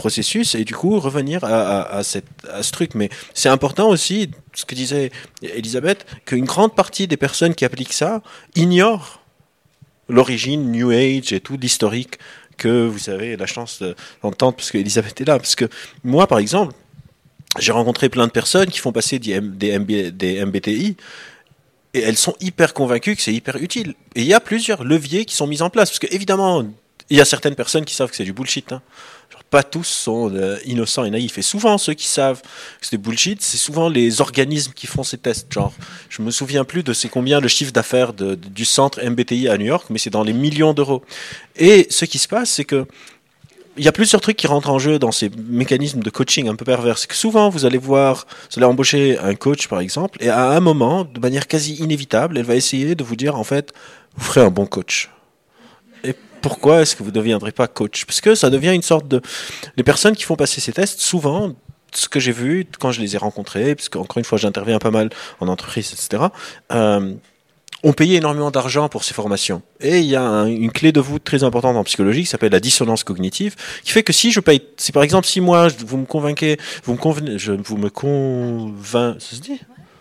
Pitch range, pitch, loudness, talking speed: 115-155 Hz, 135 Hz, -17 LUFS, 225 wpm